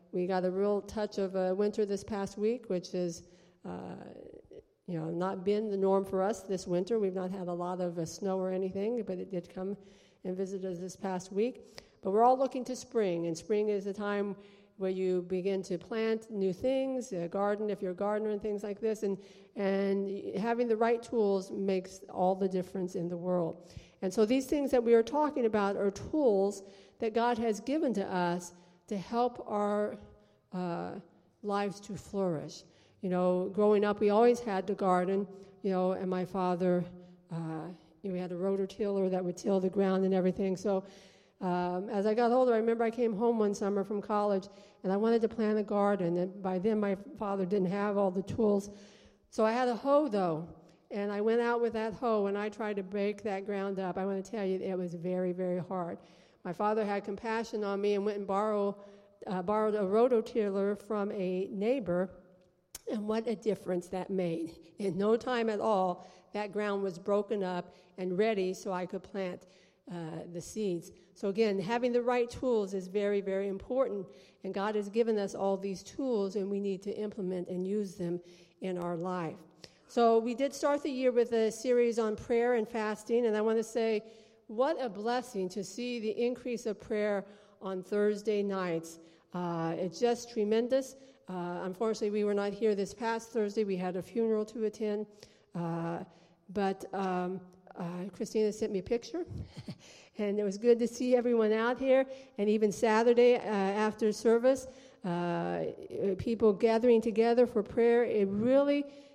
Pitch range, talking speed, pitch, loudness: 185-225 Hz, 195 wpm, 200 Hz, -32 LUFS